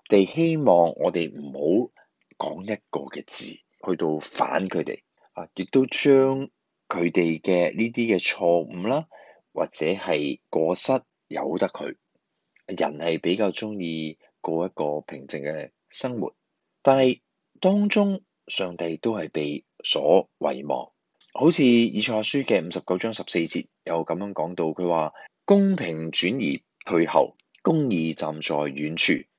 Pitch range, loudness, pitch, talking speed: 80-130 Hz, -24 LUFS, 90 Hz, 195 characters per minute